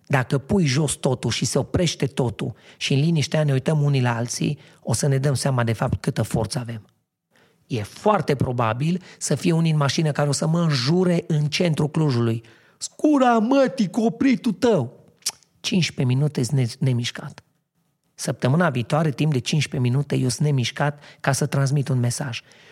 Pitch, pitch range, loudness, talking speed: 145 Hz, 130-165 Hz, -22 LUFS, 170 wpm